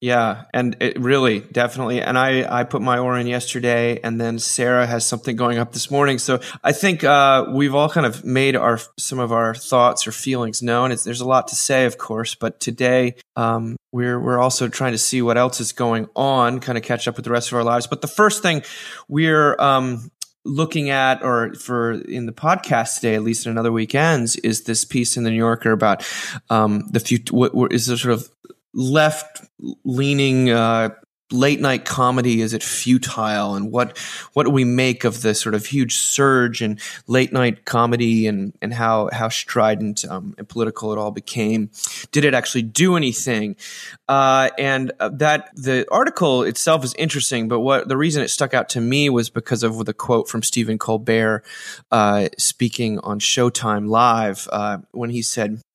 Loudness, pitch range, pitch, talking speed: -19 LUFS, 115-130 Hz, 120 Hz, 190 wpm